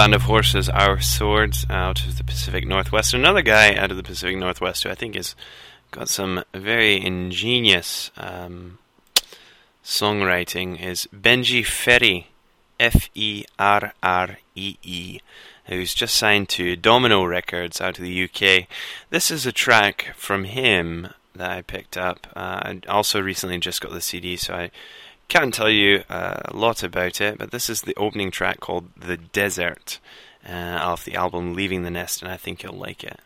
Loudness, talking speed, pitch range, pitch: -20 LUFS, 175 wpm, 90-105 Hz, 90 Hz